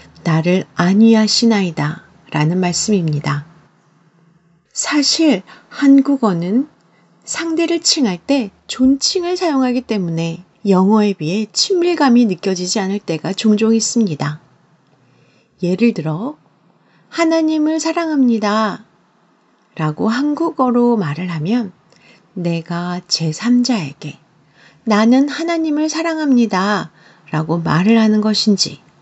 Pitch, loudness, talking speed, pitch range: 210 Hz, -16 LUFS, 225 characters per minute, 170-255 Hz